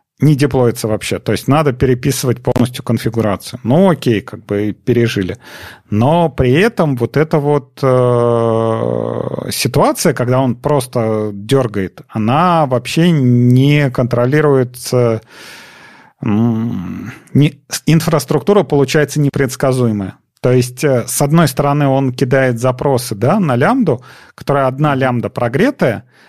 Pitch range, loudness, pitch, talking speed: 115-145 Hz, -14 LUFS, 130 Hz, 115 wpm